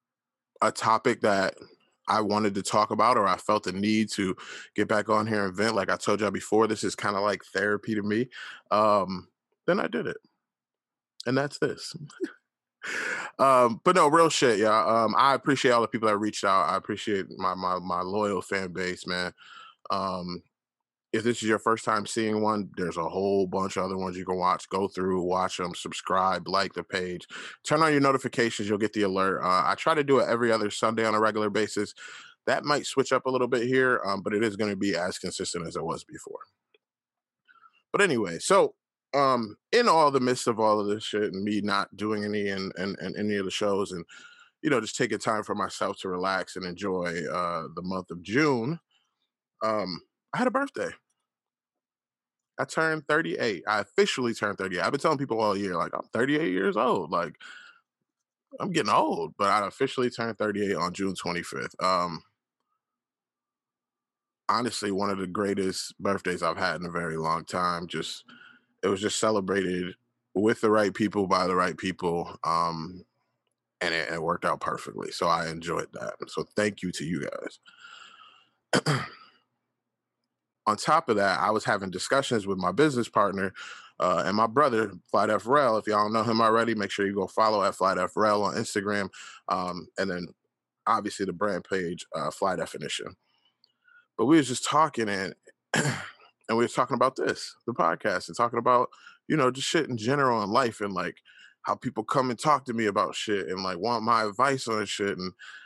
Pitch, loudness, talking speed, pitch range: 105 Hz, -27 LUFS, 195 wpm, 95-120 Hz